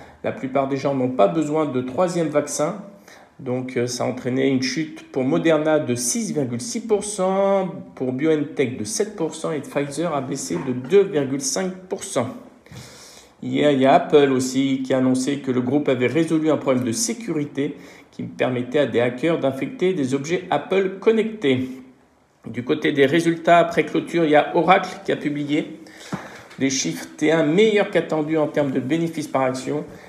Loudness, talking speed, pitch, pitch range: -21 LUFS, 165 wpm, 150 Hz, 135-165 Hz